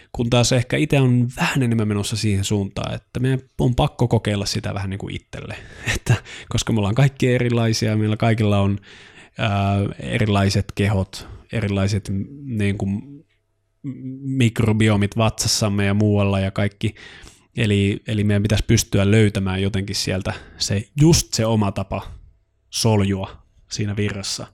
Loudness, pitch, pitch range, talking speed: -20 LUFS, 105 Hz, 100-115 Hz, 140 wpm